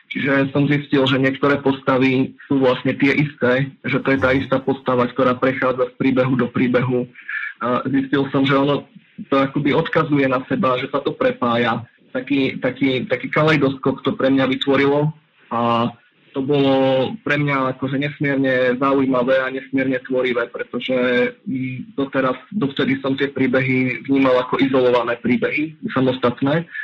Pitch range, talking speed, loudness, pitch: 130-140 Hz, 145 wpm, -19 LUFS, 135 Hz